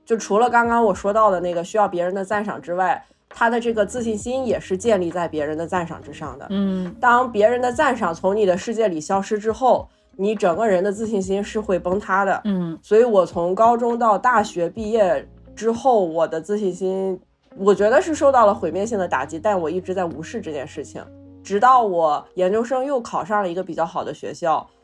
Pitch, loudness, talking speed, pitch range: 200 Hz, -20 LUFS, 315 characters per minute, 180-230 Hz